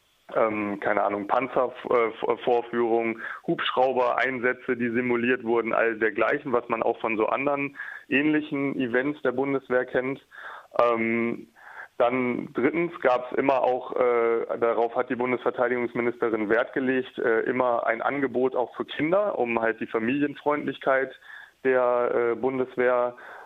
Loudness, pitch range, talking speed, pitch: -25 LUFS, 120-130 Hz, 130 wpm, 125 Hz